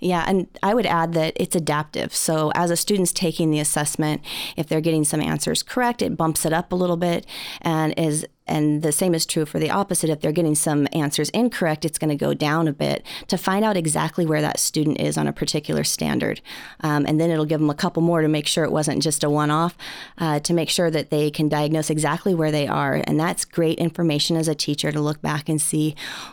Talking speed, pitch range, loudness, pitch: 235 wpm, 150-170 Hz, -21 LUFS, 160 Hz